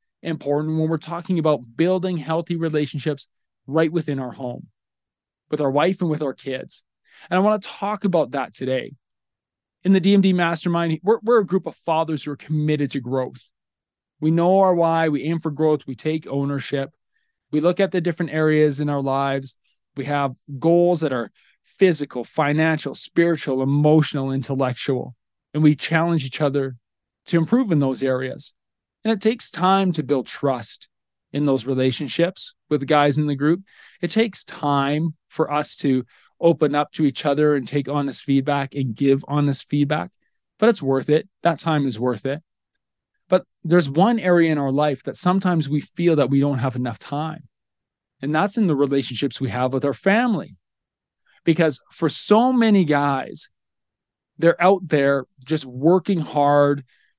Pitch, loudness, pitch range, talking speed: 150 Hz, -21 LUFS, 135-170 Hz, 170 wpm